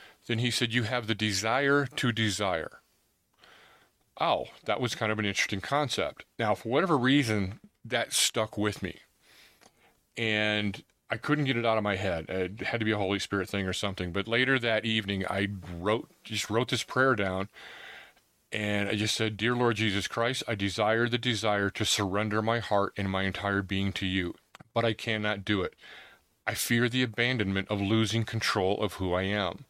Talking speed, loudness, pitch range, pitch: 190 wpm, -29 LUFS, 100-115 Hz, 105 Hz